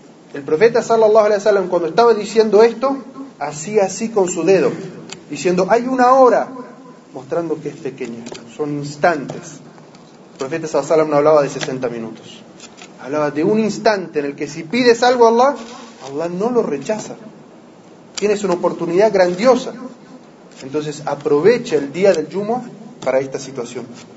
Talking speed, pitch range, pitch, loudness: 150 wpm, 150-230 Hz, 185 Hz, -16 LUFS